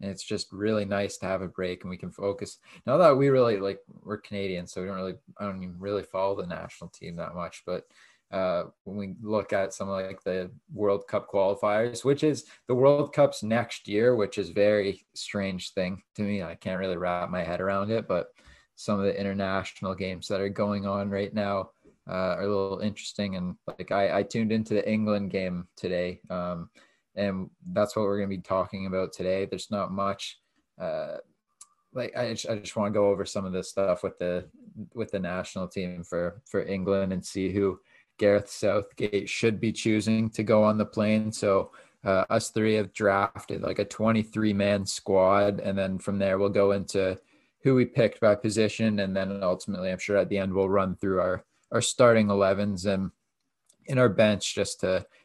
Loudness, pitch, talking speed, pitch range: -28 LUFS, 100 Hz, 205 wpm, 95-105 Hz